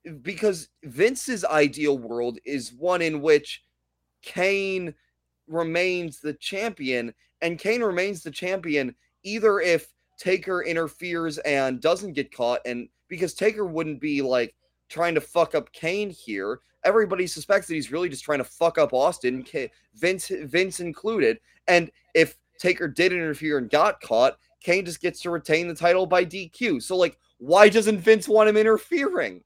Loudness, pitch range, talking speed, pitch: -24 LUFS, 150-190 Hz, 155 wpm, 170 Hz